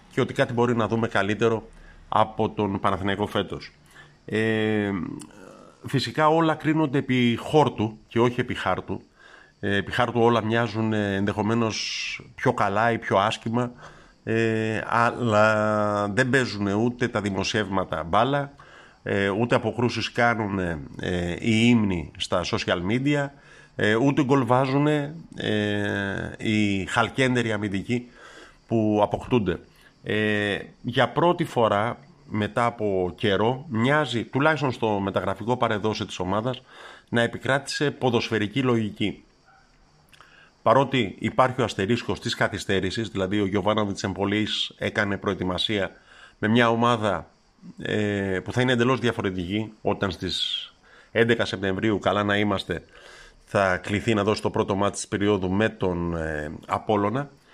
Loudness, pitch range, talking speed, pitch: -24 LUFS, 100-120 Hz, 120 wpm, 110 Hz